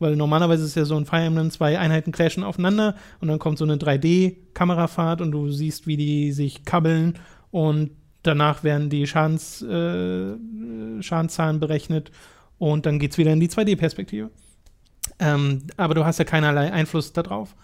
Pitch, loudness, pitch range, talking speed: 155 Hz, -22 LUFS, 150-165 Hz, 165 wpm